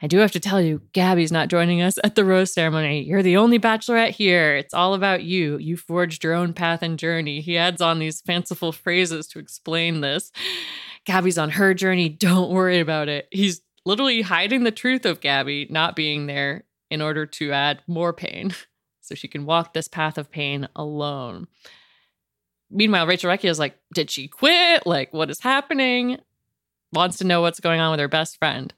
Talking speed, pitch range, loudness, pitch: 195 wpm, 155-190 Hz, -21 LUFS, 170 Hz